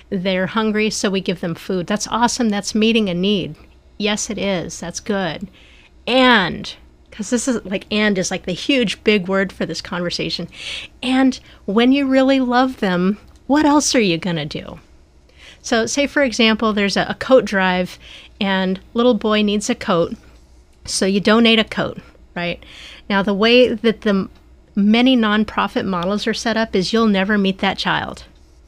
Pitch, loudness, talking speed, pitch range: 205 Hz, -17 LUFS, 175 wpm, 185-230 Hz